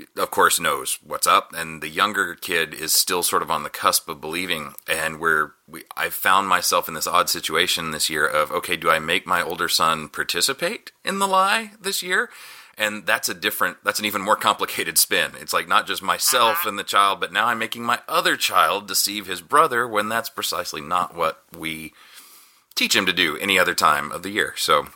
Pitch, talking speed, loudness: 115 Hz, 215 wpm, -21 LUFS